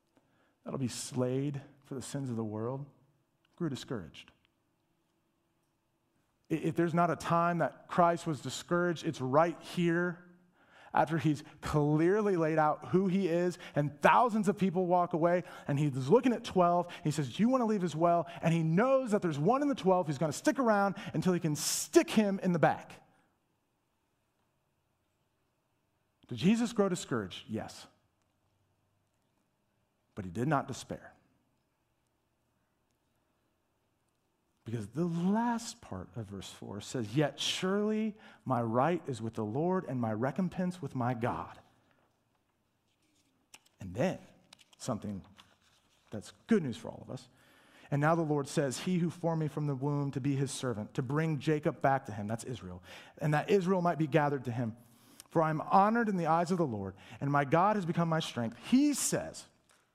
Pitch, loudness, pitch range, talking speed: 150 Hz, -32 LUFS, 125-175 Hz, 165 wpm